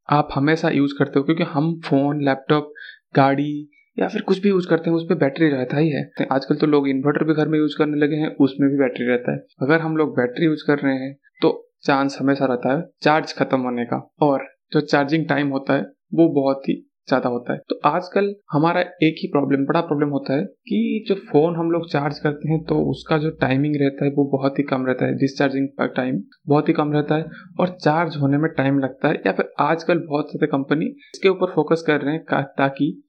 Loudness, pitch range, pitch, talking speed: -20 LUFS, 140-165 Hz, 150 Hz, 225 wpm